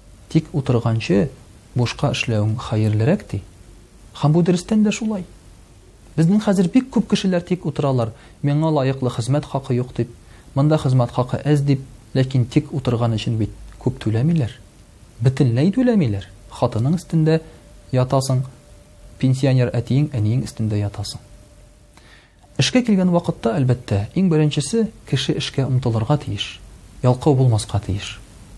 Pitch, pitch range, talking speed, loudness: 125 Hz, 110-150 Hz, 120 wpm, -20 LUFS